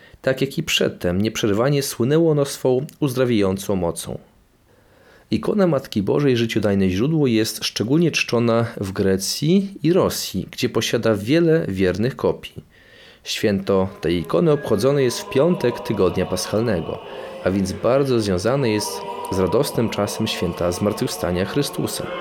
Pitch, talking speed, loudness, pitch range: 115 Hz, 125 wpm, -20 LUFS, 100-140 Hz